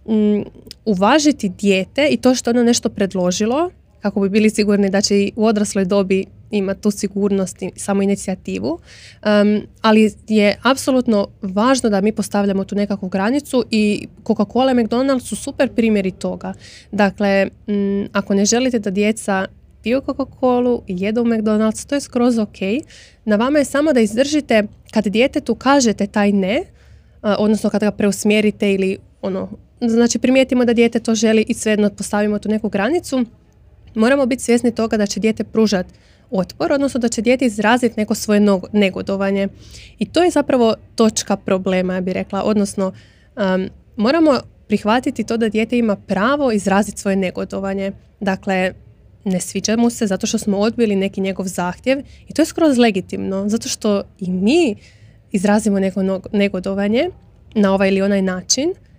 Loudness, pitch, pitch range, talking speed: -17 LUFS, 210 Hz, 195-235 Hz, 165 wpm